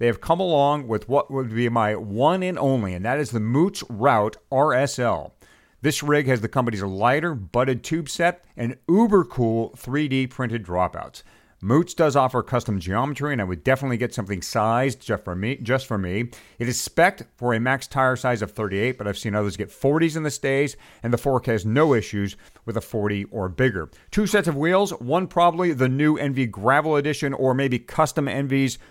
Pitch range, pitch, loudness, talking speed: 110-145 Hz, 130 Hz, -23 LUFS, 200 wpm